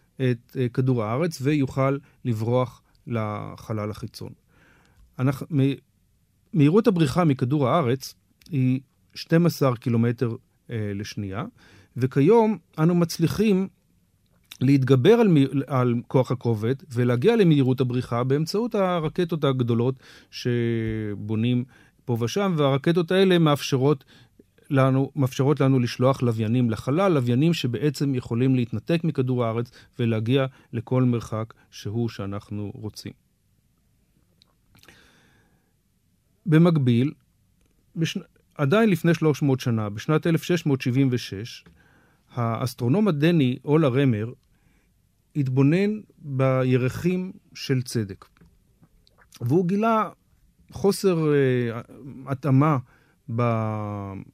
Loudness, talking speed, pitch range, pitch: -23 LUFS, 85 wpm, 120-155 Hz, 130 Hz